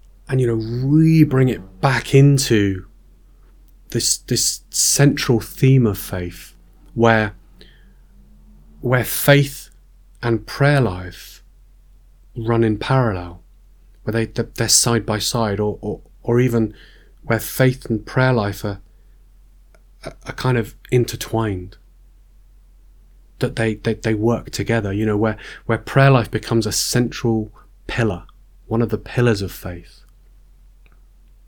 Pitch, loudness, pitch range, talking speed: 110 Hz, -18 LUFS, 100-120 Hz, 125 wpm